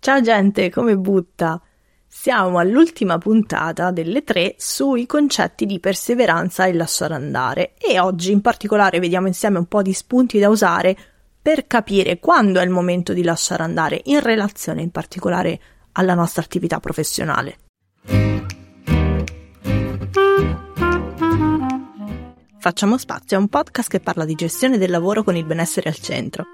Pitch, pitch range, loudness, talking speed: 185 Hz, 165-210 Hz, -18 LUFS, 140 wpm